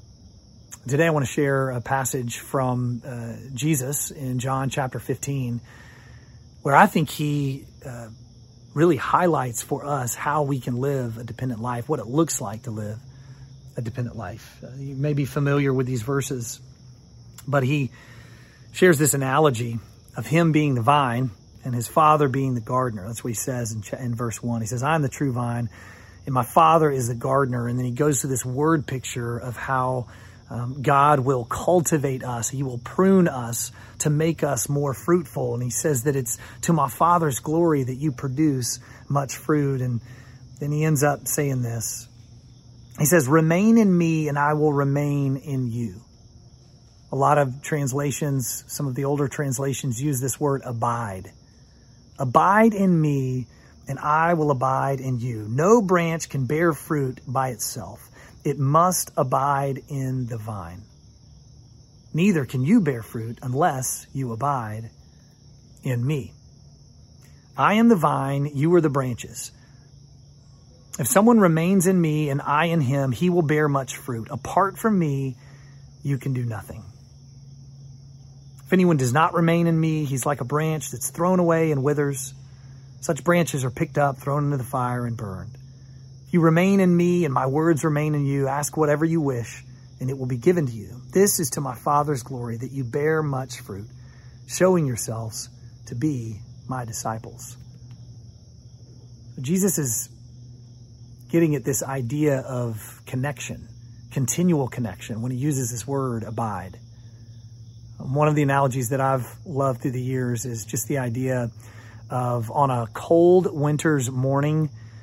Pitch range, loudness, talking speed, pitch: 120-145 Hz, -23 LUFS, 165 wpm, 135 Hz